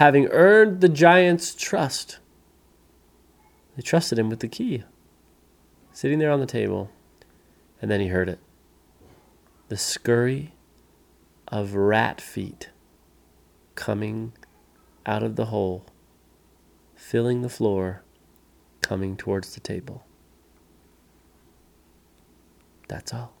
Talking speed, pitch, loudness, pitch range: 105 wpm, 95 Hz, -23 LUFS, 85-115 Hz